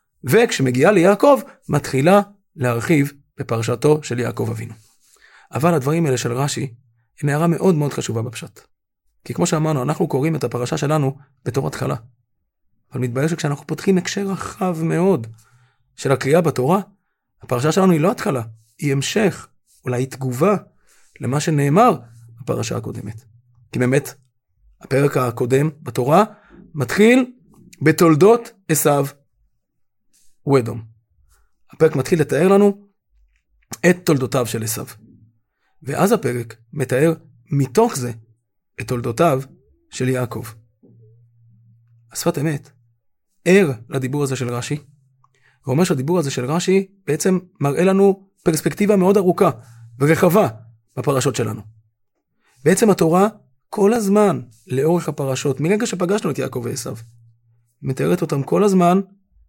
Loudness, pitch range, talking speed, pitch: -18 LUFS, 120-175 Hz, 115 wpm, 140 Hz